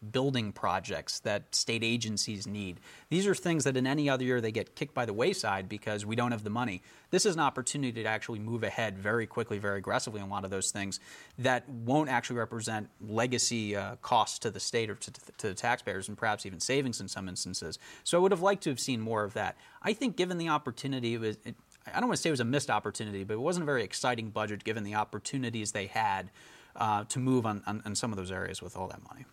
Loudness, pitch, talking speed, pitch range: -32 LUFS, 115 Hz, 250 wpm, 105-130 Hz